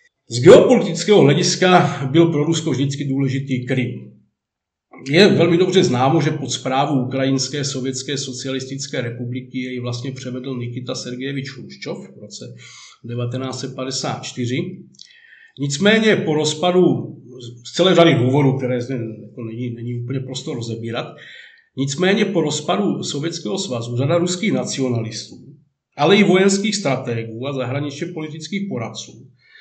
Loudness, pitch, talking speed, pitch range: -18 LUFS, 135 Hz, 120 wpm, 125-165 Hz